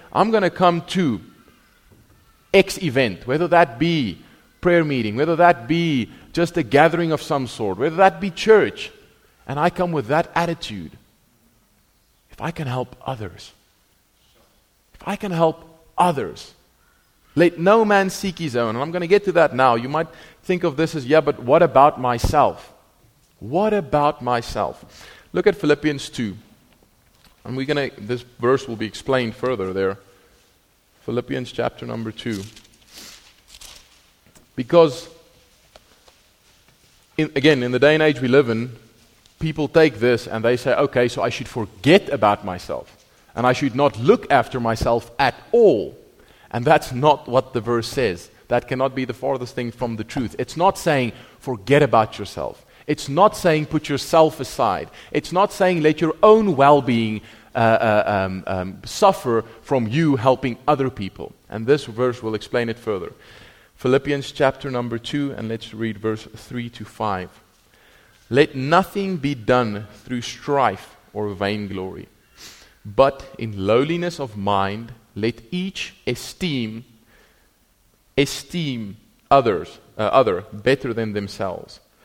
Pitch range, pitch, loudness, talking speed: 110-155 Hz, 130 Hz, -20 LUFS, 150 wpm